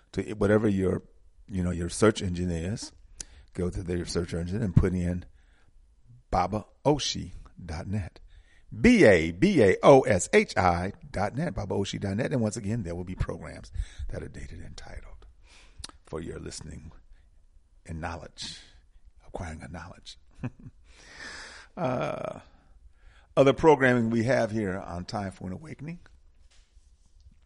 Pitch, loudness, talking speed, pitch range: 90 Hz, -26 LUFS, 110 wpm, 80-105 Hz